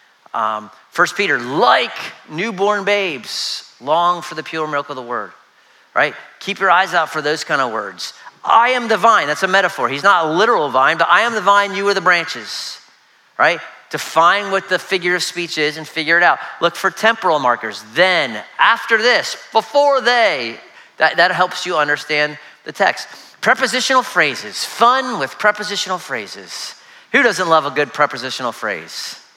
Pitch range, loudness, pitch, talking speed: 150-210 Hz, -16 LUFS, 180 Hz, 175 wpm